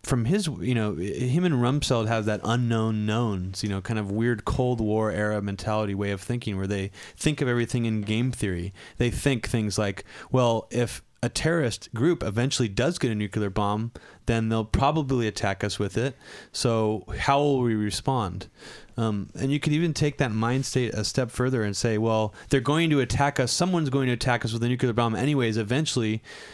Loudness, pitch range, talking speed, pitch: -26 LUFS, 105-130 Hz, 200 wpm, 115 Hz